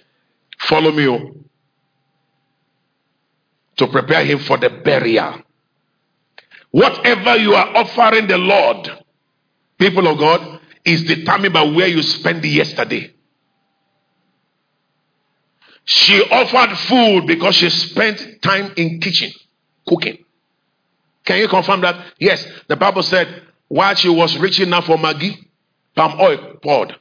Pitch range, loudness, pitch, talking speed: 160-200 Hz, -14 LUFS, 180 Hz, 120 wpm